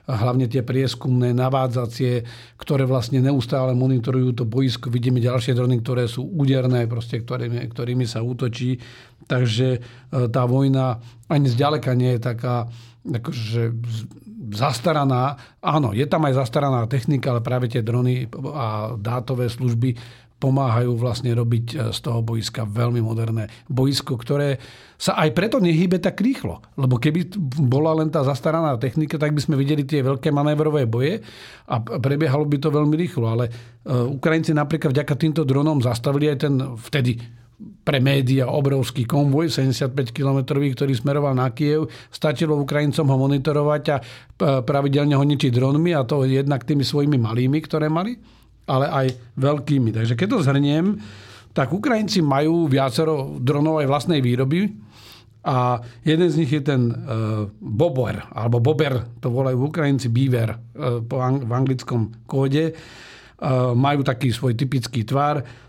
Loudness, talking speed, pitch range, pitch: -21 LUFS, 140 wpm, 120-145 Hz, 130 Hz